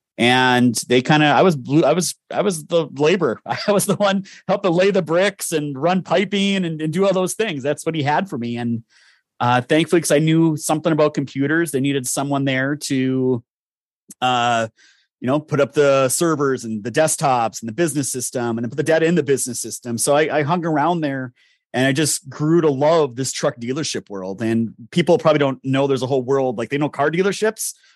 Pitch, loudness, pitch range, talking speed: 145 Hz, -19 LUFS, 130-165 Hz, 220 wpm